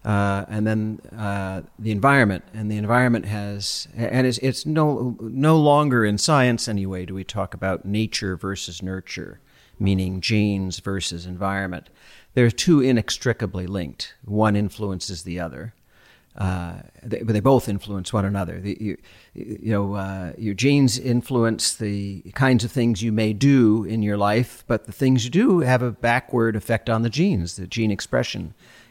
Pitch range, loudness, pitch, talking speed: 95-120 Hz, -22 LUFS, 105 Hz, 165 wpm